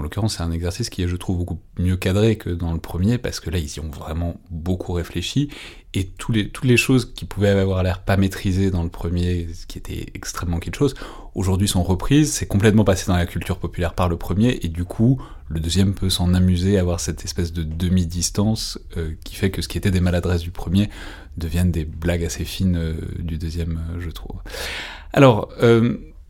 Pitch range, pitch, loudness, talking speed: 85-100 Hz, 90 Hz, -21 LUFS, 220 wpm